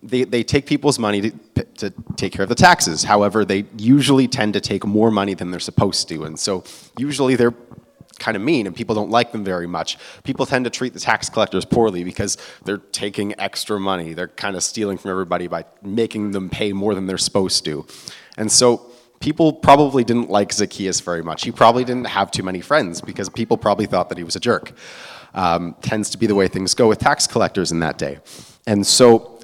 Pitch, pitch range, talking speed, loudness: 105 Hz, 95-120 Hz, 220 wpm, -18 LUFS